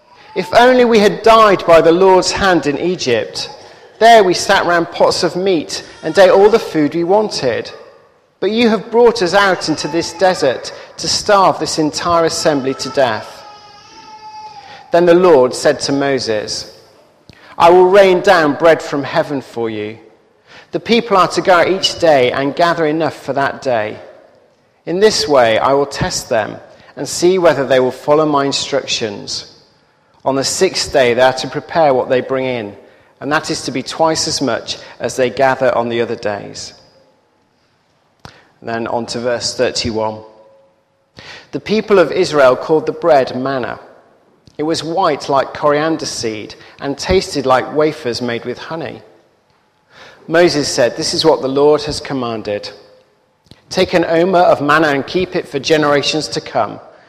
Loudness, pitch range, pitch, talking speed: -13 LUFS, 135-185 Hz, 155 Hz, 170 wpm